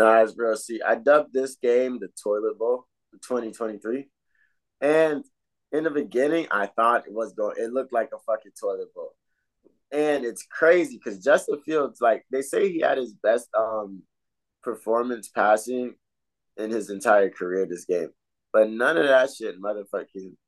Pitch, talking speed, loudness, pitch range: 125 Hz, 165 wpm, -24 LUFS, 110-160 Hz